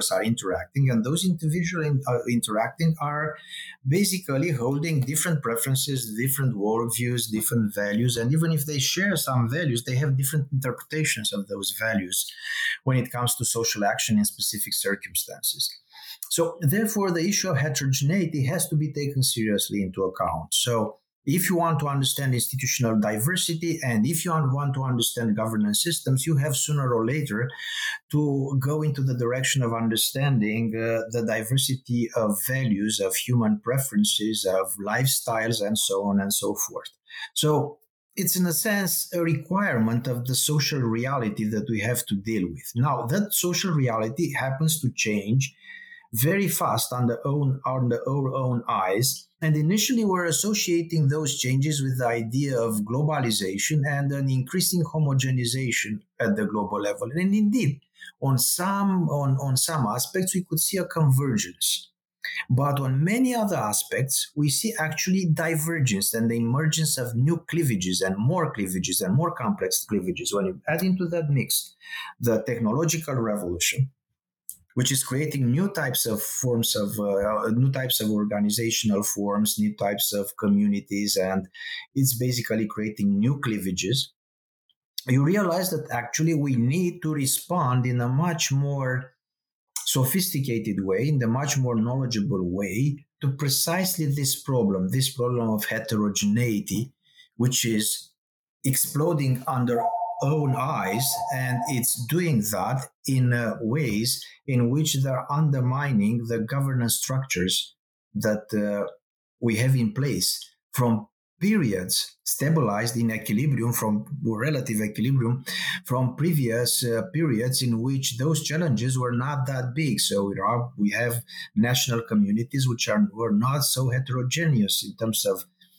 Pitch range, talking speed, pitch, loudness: 115-155 Hz, 145 wpm, 130 Hz, -24 LUFS